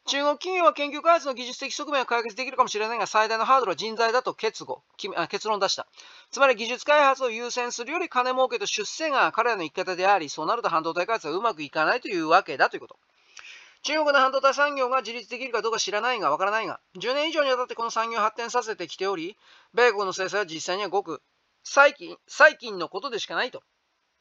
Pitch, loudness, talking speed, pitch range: 250 Hz, -24 LUFS, 450 characters per minute, 215-290 Hz